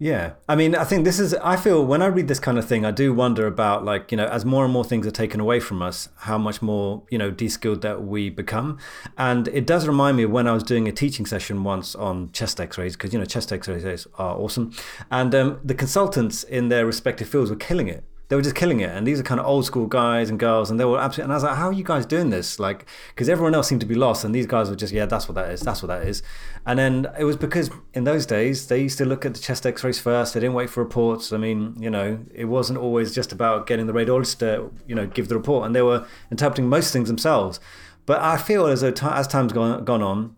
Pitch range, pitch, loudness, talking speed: 110-135 Hz, 120 Hz, -22 LUFS, 280 wpm